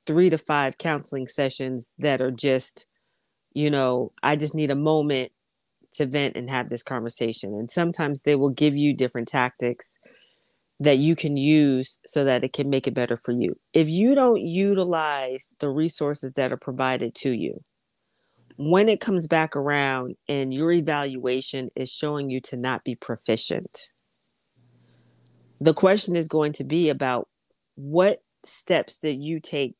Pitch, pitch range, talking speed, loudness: 140 Hz, 130-155 Hz, 160 wpm, -24 LUFS